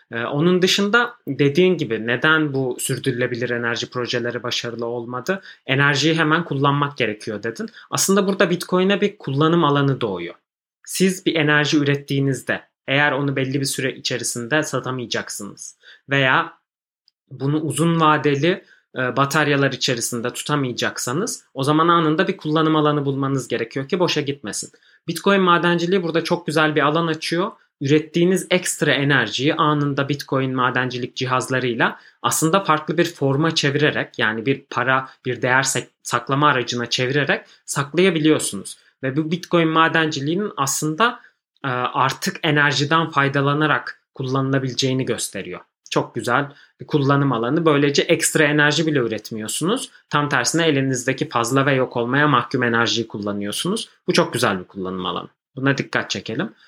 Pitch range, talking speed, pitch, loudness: 125-160 Hz, 125 wpm, 145 Hz, -20 LUFS